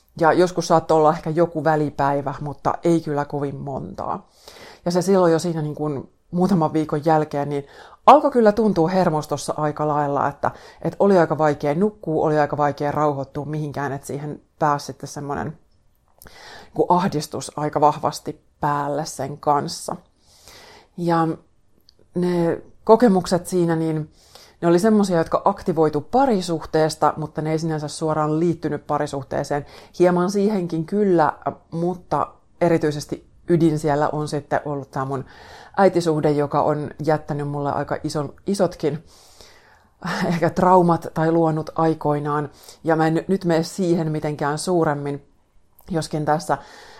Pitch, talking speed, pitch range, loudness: 155 Hz, 135 wpm, 145-170 Hz, -21 LUFS